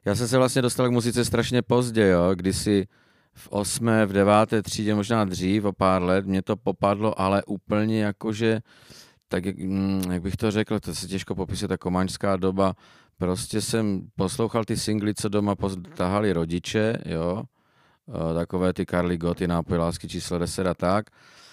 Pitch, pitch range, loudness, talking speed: 100 Hz, 95-110 Hz, -25 LUFS, 165 wpm